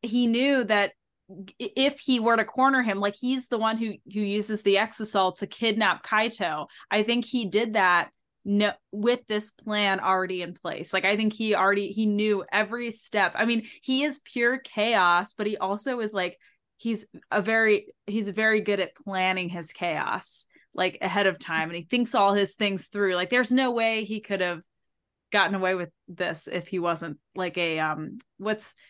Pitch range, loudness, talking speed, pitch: 190-225 Hz, -25 LUFS, 190 wpm, 210 Hz